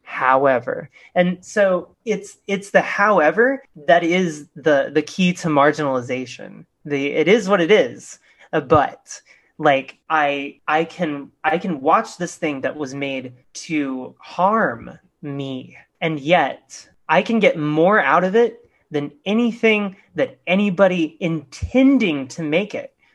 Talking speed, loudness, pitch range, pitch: 135 wpm, -19 LUFS, 145-200 Hz, 165 Hz